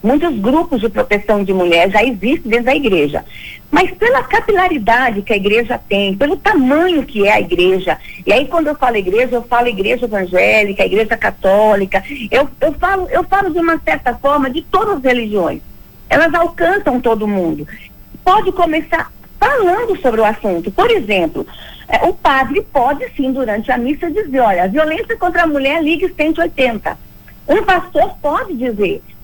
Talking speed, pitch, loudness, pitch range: 165 wpm, 275 Hz, -14 LUFS, 220-345 Hz